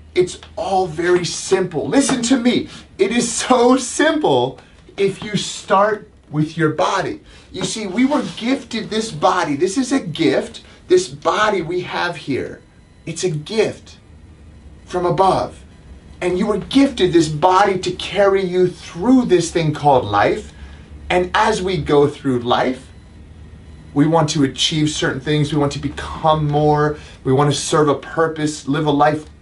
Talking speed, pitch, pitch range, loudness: 160 wpm, 170 Hz, 140-200 Hz, -17 LUFS